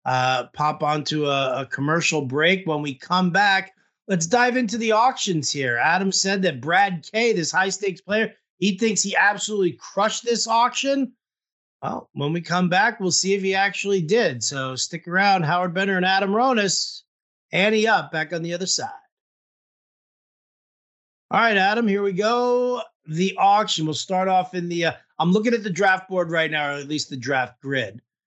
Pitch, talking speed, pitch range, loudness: 185 Hz, 185 wpm, 155-205 Hz, -21 LUFS